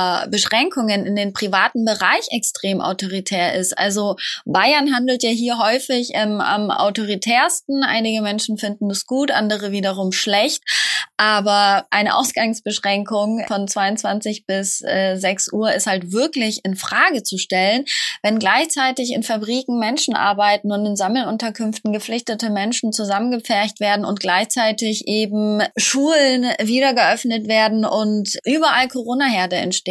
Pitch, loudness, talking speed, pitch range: 215 Hz, -18 LUFS, 130 wpm, 200-245 Hz